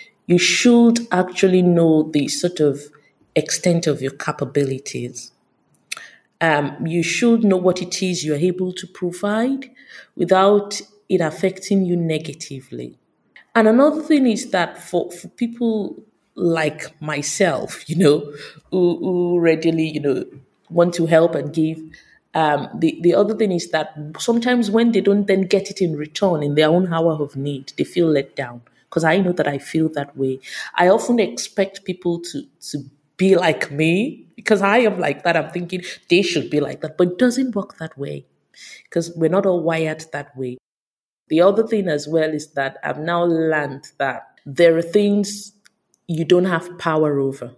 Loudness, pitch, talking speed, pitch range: -19 LUFS, 170 Hz, 170 wpm, 150-195 Hz